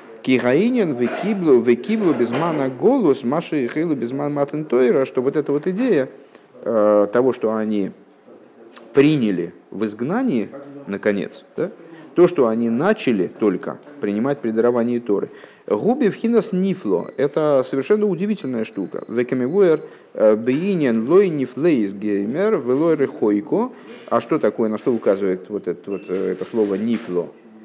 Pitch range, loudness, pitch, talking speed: 110-170 Hz, -20 LUFS, 125 Hz, 120 wpm